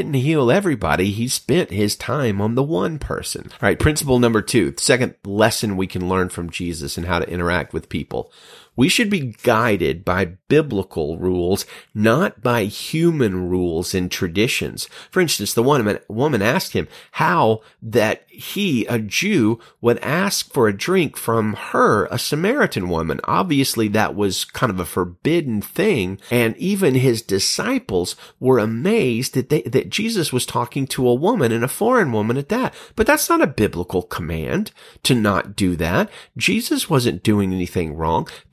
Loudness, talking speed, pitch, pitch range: -19 LUFS, 165 wpm, 115 Hz, 95-145 Hz